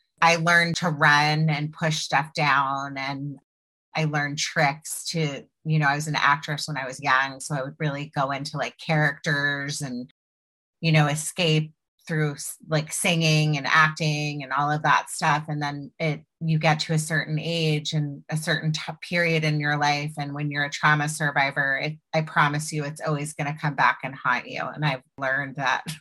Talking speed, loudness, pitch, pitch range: 195 wpm, -24 LUFS, 150 Hz, 145-155 Hz